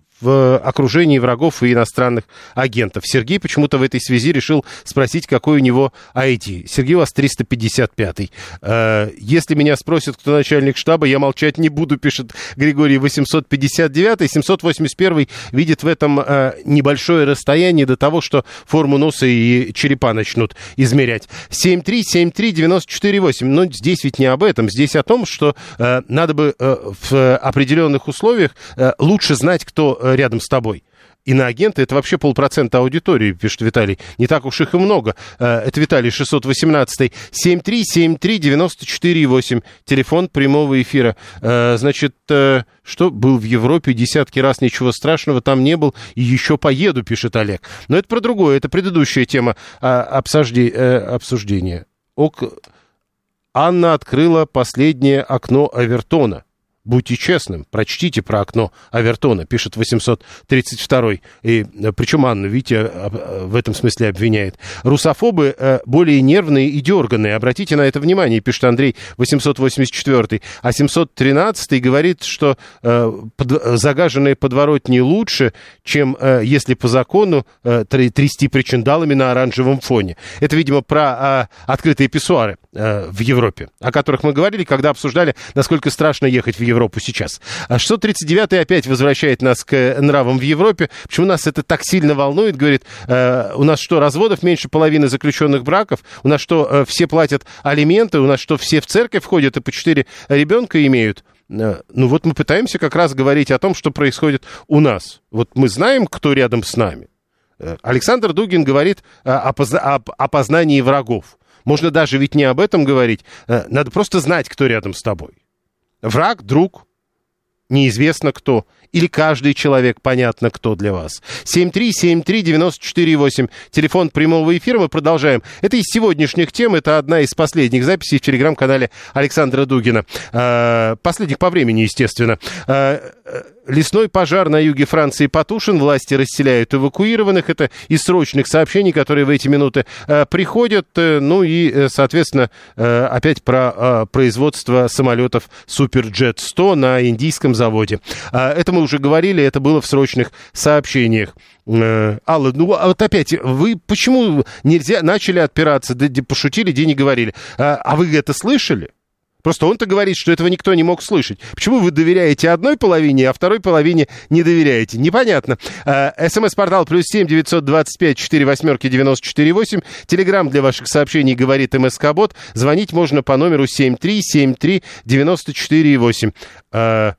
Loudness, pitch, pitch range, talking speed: -14 LUFS, 140 Hz, 125-160 Hz, 140 wpm